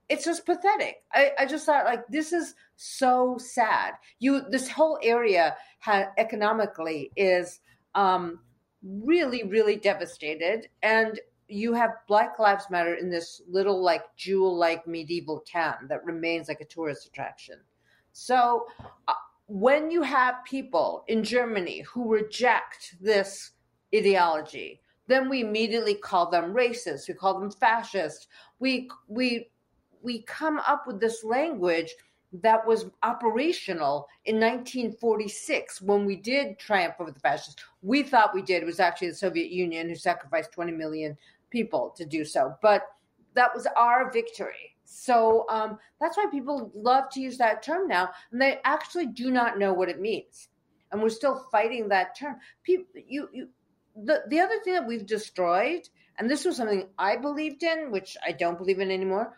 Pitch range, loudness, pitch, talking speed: 190-265 Hz, -26 LUFS, 225 Hz, 160 wpm